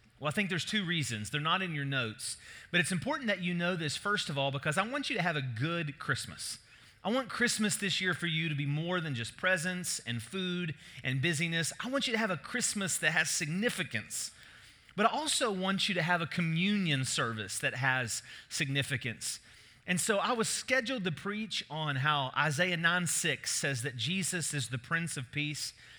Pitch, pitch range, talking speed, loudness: 170 Hz, 140-190 Hz, 205 wpm, -32 LUFS